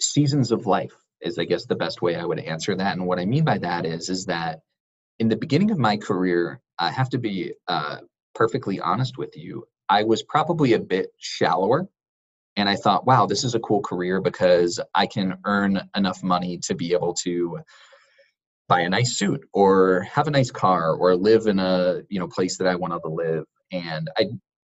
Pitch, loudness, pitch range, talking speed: 95 Hz, -23 LUFS, 90-110 Hz, 205 wpm